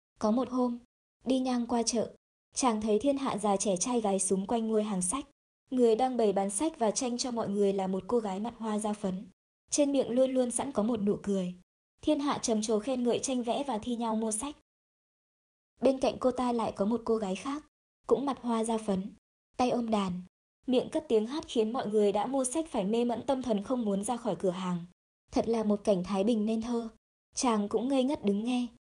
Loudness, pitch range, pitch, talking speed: -31 LUFS, 210-255 Hz, 230 Hz, 235 wpm